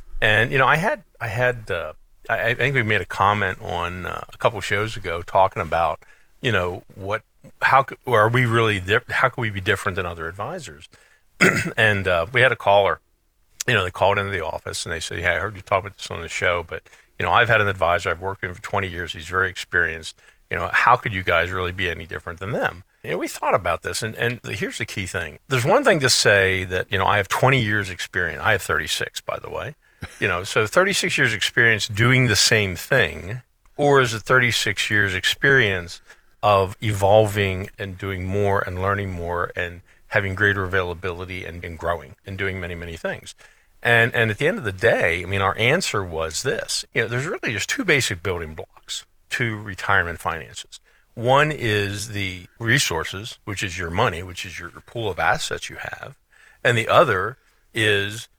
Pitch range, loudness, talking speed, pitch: 90-115 Hz, -21 LUFS, 215 wpm, 100 Hz